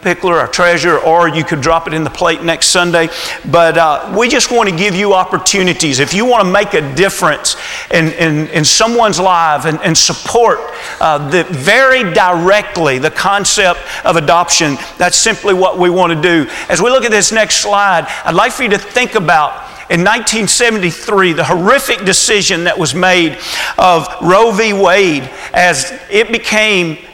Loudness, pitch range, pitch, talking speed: -10 LUFS, 165-205 Hz, 180 Hz, 180 wpm